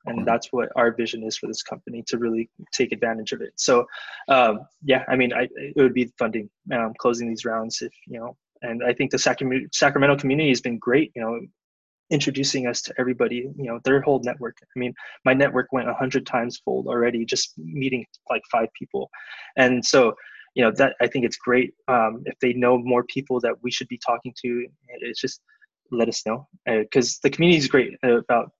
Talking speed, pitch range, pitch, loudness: 210 wpm, 115-135 Hz, 125 Hz, -23 LUFS